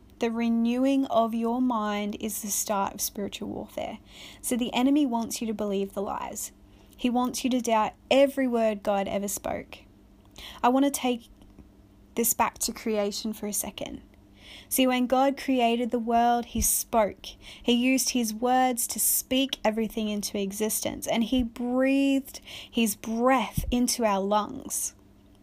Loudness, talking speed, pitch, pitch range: -26 LUFS, 155 wpm, 230 Hz, 210-255 Hz